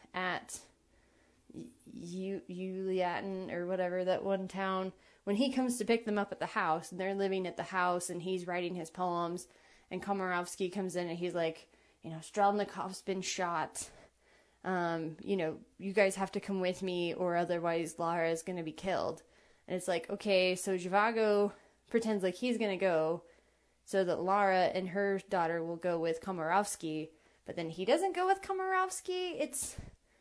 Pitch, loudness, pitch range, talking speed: 185 Hz, -34 LUFS, 175-200 Hz, 175 wpm